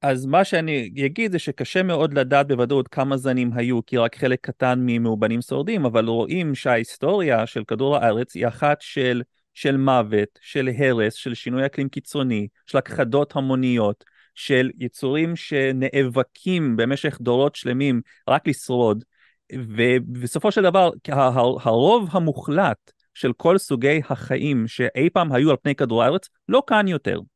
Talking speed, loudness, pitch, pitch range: 145 wpm, -21 LUFS, 135 Hz, 120-145 Hz